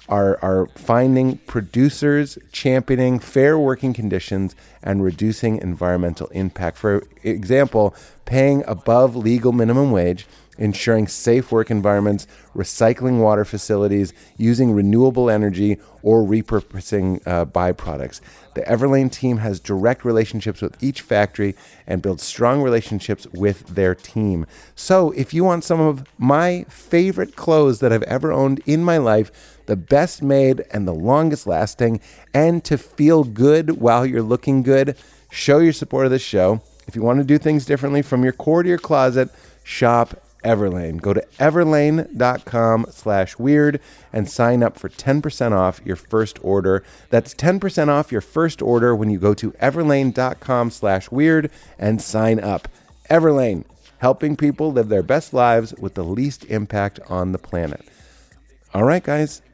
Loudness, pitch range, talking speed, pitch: -18 LUFS, 100-140 Hz, 145 wpm, 120 Hz